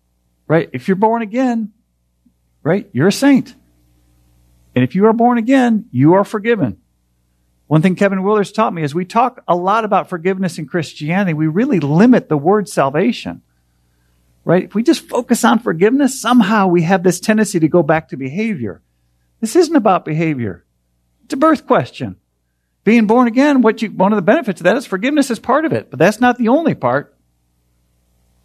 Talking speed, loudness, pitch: 185 wpm, -15 LUFS, 180 Hz